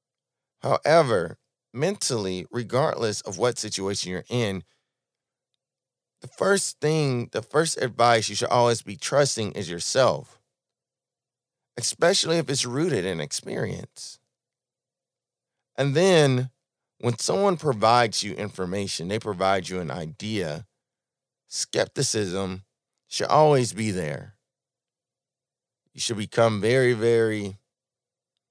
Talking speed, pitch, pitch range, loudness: 105 wpm, 120 Hz, 100-135 Hz, -24 LUFS